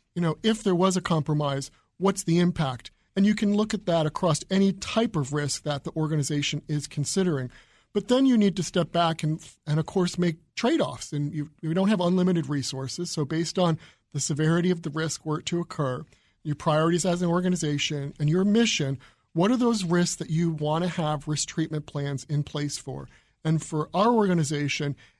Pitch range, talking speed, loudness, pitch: 150-180 Hz, 200 wpm, -26 LUFS, 160 Hz